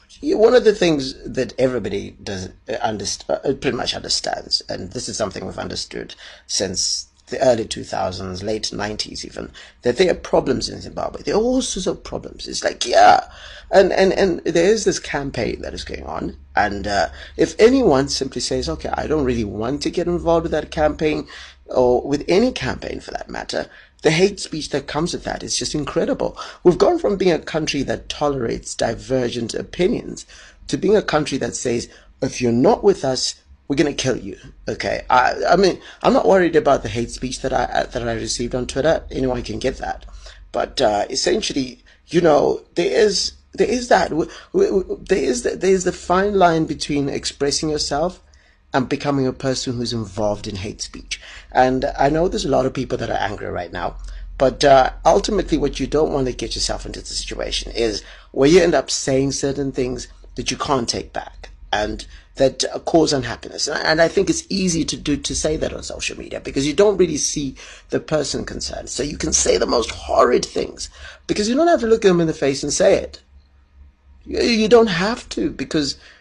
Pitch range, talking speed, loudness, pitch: 120-175 Hz, 200 wpm, -19 LUFS, 140 Hz